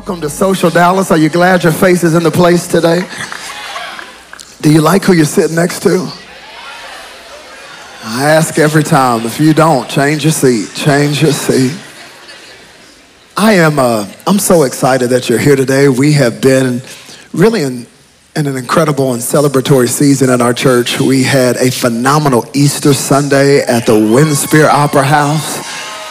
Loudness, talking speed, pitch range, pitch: -10 LUFS, 160 wpm, 130-160 Hz, 145 Hz